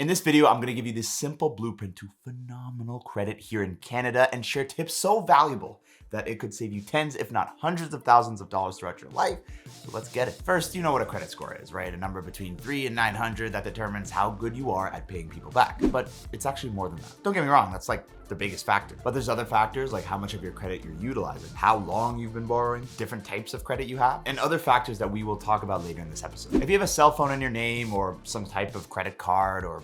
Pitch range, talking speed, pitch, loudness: 100-125 Hz, 265 wpm, 115 Hz, -27 LUFS